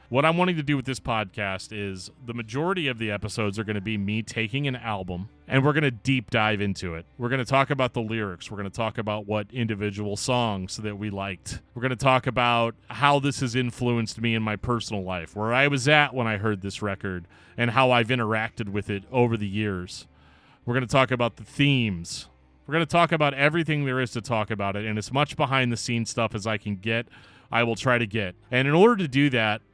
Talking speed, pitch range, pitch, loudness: 245 wpm, 105-130 Hz, 115 Hz, -25 LUFS